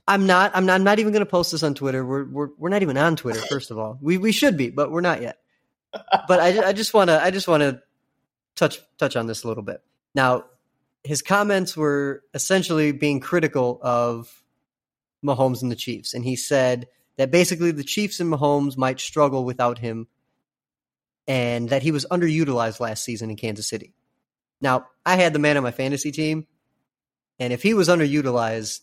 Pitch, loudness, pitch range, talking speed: 140 Hz, -21 LUFS, 125-170 Hz, 200 wpm